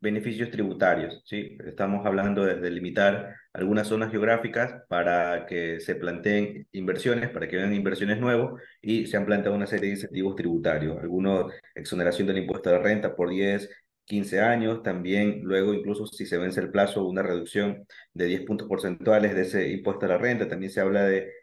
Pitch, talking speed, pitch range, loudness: 100 Hz, 180 wpm, 95-105 Hz, -26 LUFS